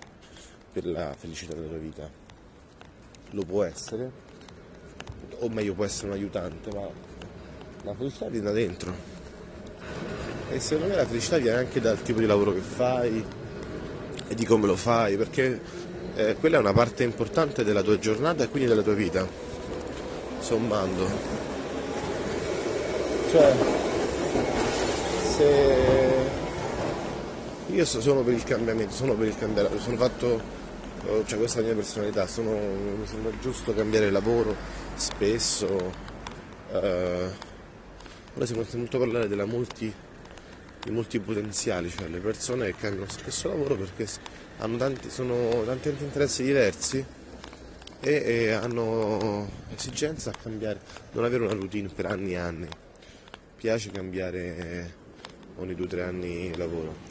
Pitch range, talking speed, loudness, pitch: 95-120 Hz, 140 wpm, -27 LUFS, 110 Hz